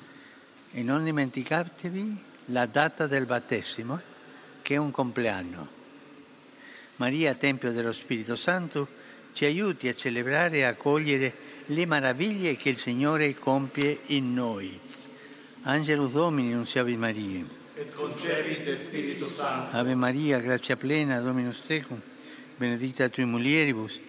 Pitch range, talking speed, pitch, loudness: 125-150 Hz, 115 wpm, 135 Hz, -28 LUFS